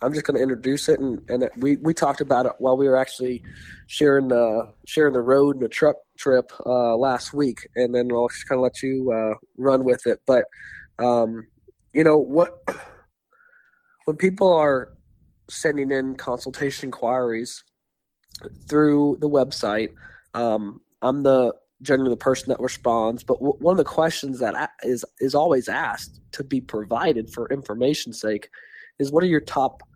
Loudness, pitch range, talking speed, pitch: -22 LUFS, 120-145 Hz, 180 wpm, 130 Hz